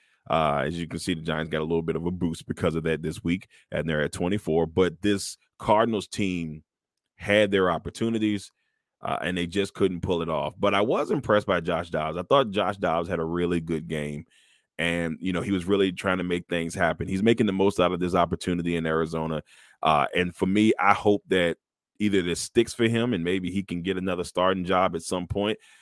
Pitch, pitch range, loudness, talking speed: 90 Hz, 85-100 Hz, -26 LUFS, 230 wpm